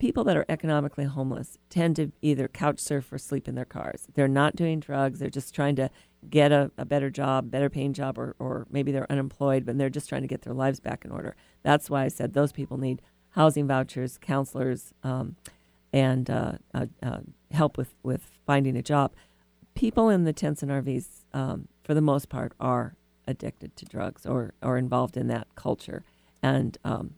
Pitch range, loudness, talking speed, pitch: 130-145 Hz, -28 LUFS, 200 wpm, 135 Hz